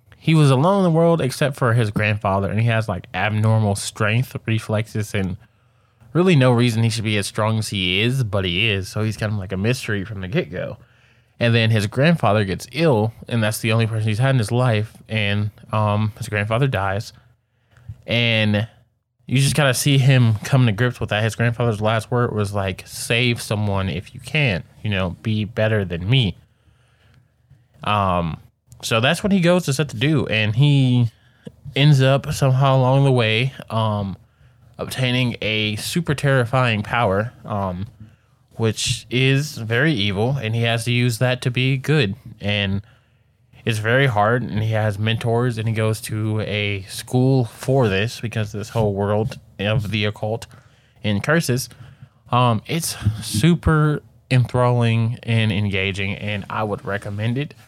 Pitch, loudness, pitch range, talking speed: 115 Hz, -20 LUFS, 105-130 Hz, 175 wpm